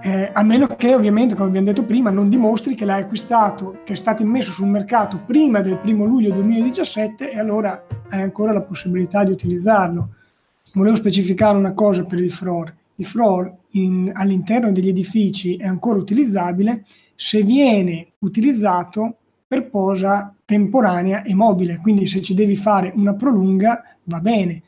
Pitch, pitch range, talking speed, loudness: 205 Hz, 190-220 Hz, 160 wpm, -18 LUFS